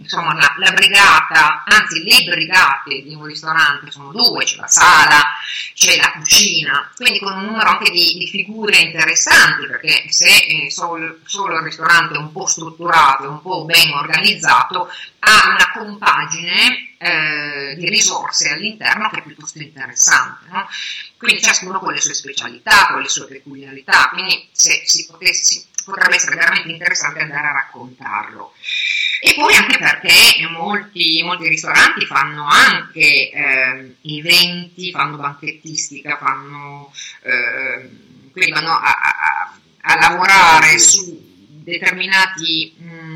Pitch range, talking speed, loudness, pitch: 150-185 Hz, 140 wpm, -12 LUFS, 165 Hz